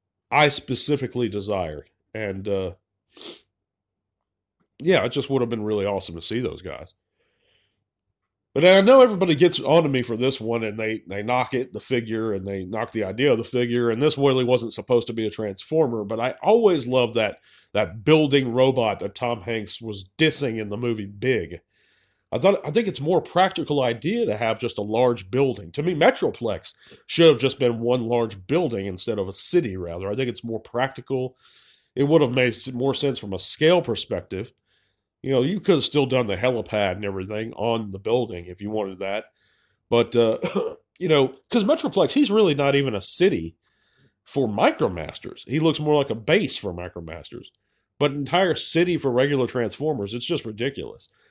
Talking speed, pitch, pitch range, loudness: 190 wpm, 120 Hz, 105-145 Hz, -22 LUFS